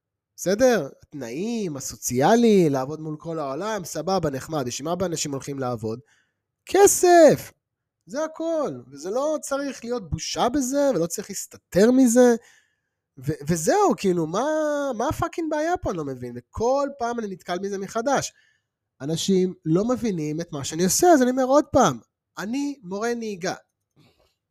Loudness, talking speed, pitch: -23 LUFS, 145 wpm, 195 Hz